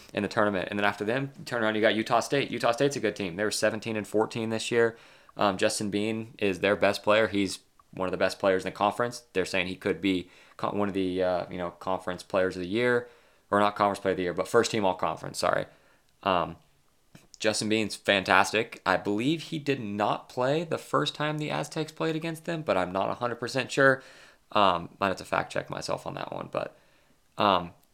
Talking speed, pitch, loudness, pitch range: 230 wpm, 110 Hz, -28 LUFS, 95-120 Hz